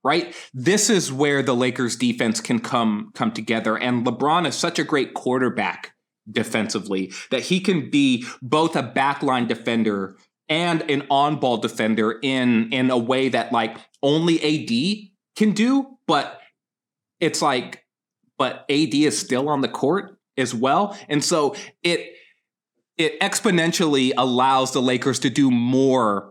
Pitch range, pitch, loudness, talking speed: 125-170 Hz, 135 Hz, -21 LUFS, 145 wpm